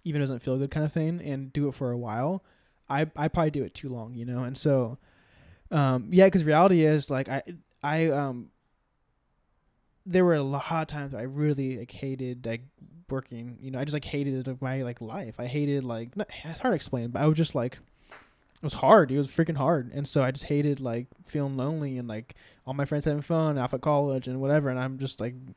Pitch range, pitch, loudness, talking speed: 125-155 Hz, 140 Hz, -28 LUFS, 235 wpm